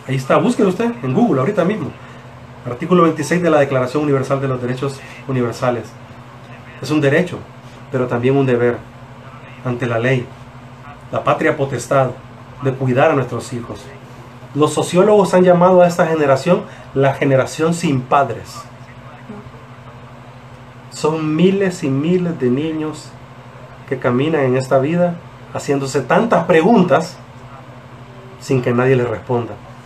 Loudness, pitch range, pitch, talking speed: -16 LUFS, 125-150 Hz, 130 Hz, 135 wpm